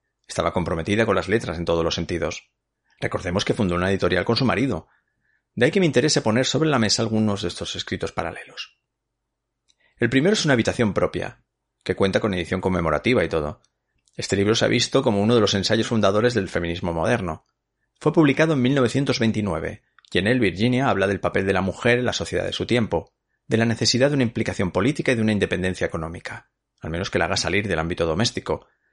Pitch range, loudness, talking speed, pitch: 90-125 Hz, -22 LUFS, 205 wpm, 105 Hz